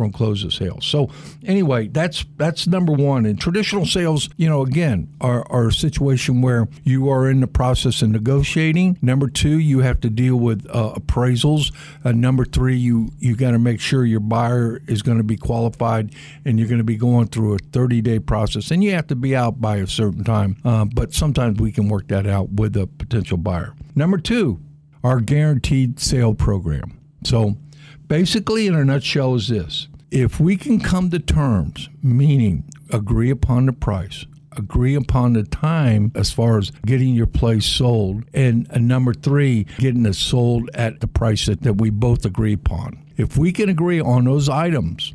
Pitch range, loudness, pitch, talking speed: 110-145 Hz, -18 LUFS, 125 Hz, 195 wpm